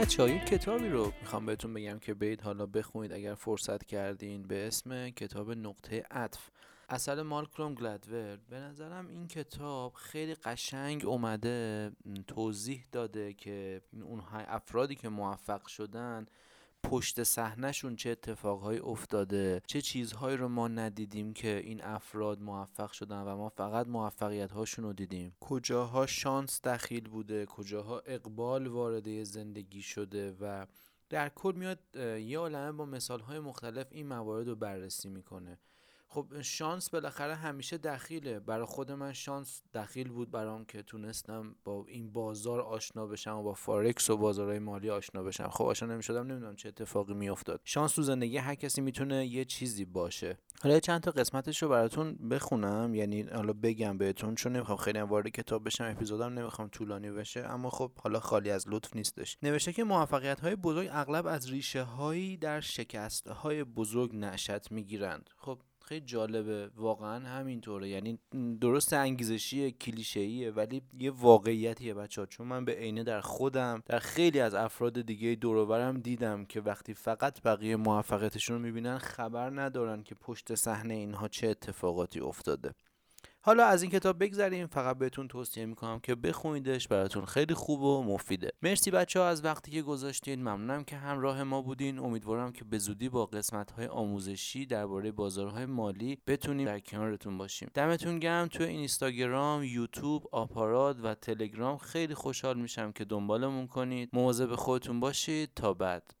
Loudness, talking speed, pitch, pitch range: -35 LUFS, 155 wpm, 115 Hz, 105-135 Hz